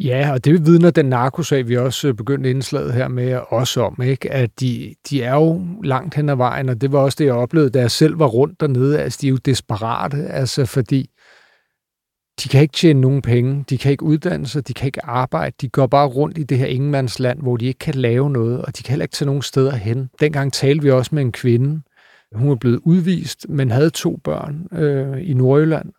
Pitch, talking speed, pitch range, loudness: 135 Hz, 230 wpm, 130-150 Hz, -17 LUFS